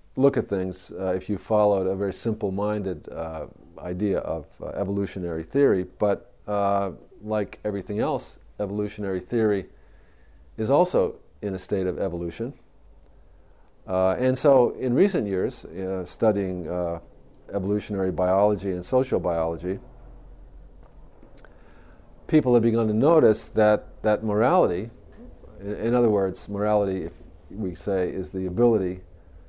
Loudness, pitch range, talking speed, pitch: -25 LUFS, 90-105 Hz, 130 wpm, 100 Hz